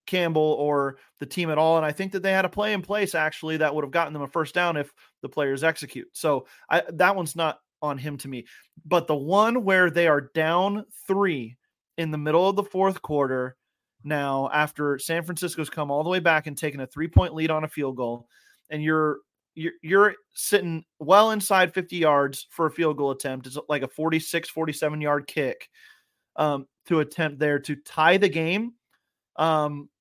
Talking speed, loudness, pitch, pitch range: 200 wpm, -24 LUFS, 155 Hz, 145-180 Hz